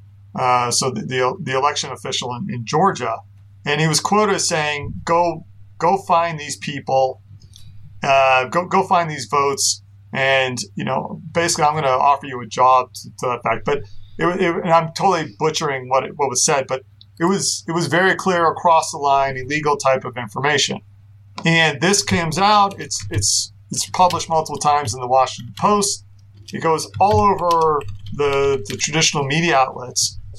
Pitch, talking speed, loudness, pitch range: 140 Hz, 180 wpm, -18 LUFS, 115-165 Hz